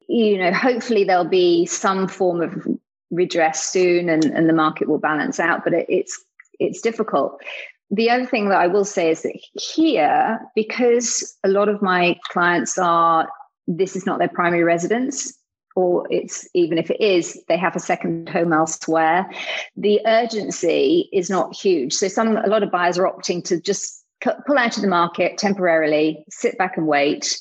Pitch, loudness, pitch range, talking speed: 195 Hz, -19 LUFS, 175-235 Hz, 180 wpm